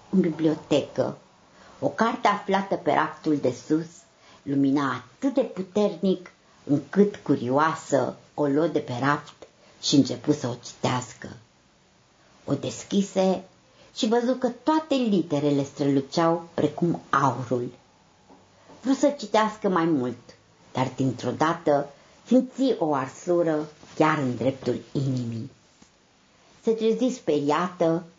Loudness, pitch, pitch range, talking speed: -25 LUFS, 155 Hz, 140-195 Hz, 110 wpm